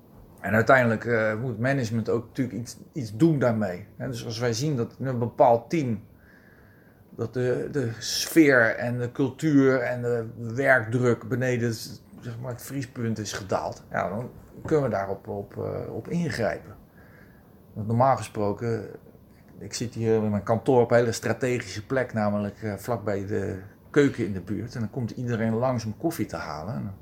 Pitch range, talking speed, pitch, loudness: 110-125 Hz, 170 wpm, 115 Hz, -26 LUFS